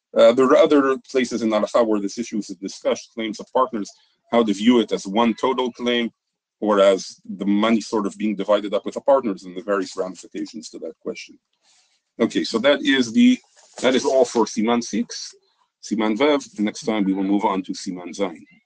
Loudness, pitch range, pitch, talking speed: -20 LUFS, 105-130 Hz, 115 Hz, 210 wpm